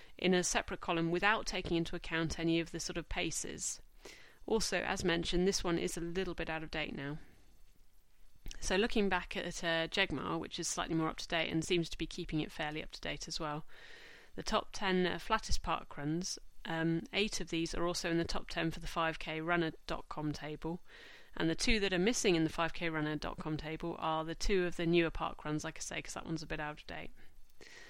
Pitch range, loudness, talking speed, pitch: 160-180 Hz, -36 LUFS, 220 wpm, 165 Hz